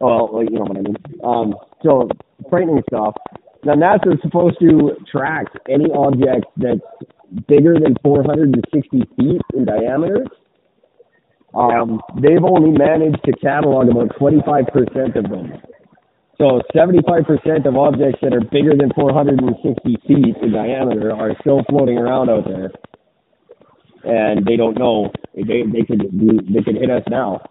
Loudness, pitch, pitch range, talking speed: -15 LUFS, 140 Hz, 120-150 Hz, 165 wpm